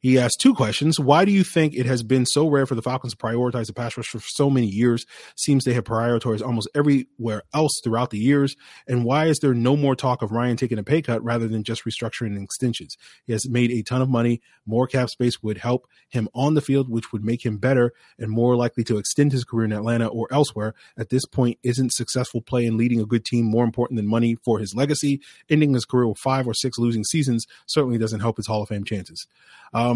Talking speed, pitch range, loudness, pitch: 240 wpm, 115-130 Hz, -22 LUFS, 120 Hz